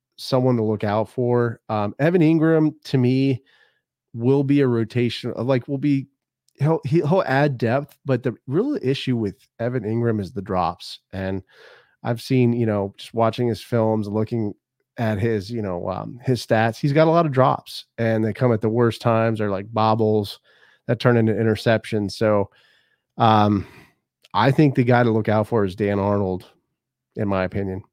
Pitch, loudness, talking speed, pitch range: 115 Hz, -21 LUFS, 180 wpm, 110-130 Hz